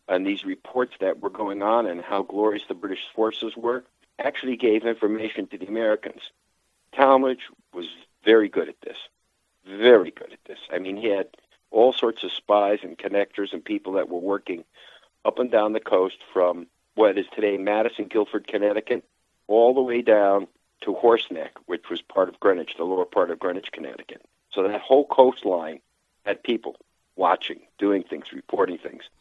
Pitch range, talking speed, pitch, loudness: 100-125 Hz, 175 wpm, 110 Hz, -23 LUFS